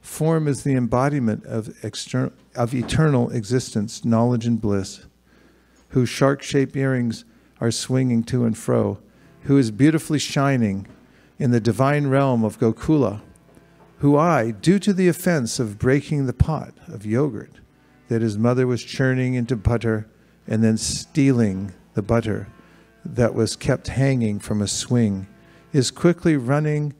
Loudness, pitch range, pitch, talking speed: -21 LUFS, 110-140 Hz, 125 Hz, 145 wpm